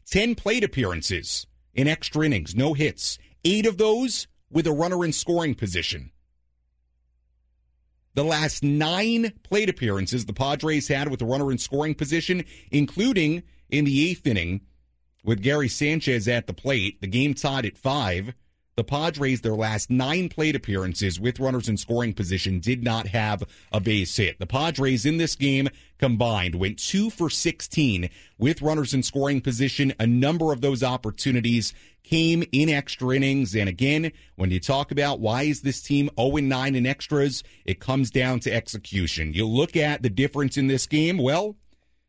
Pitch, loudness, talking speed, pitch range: 135 Hz, -24 LUFS, 165 wpm, 105-150 Hz